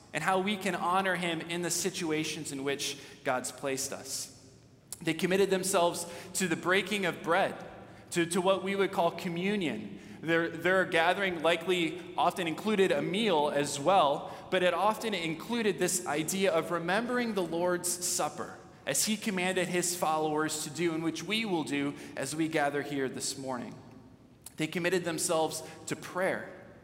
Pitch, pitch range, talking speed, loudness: 170 Hz, 155-185 Hz, 165 wpm, -30 LUFS